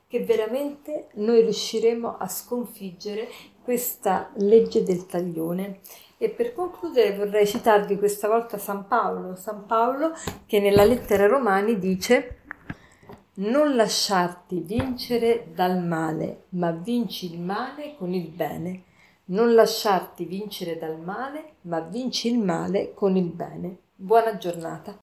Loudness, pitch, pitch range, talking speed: -24 LUFS, 210 Hz, 185-235 Hz, 125 wpm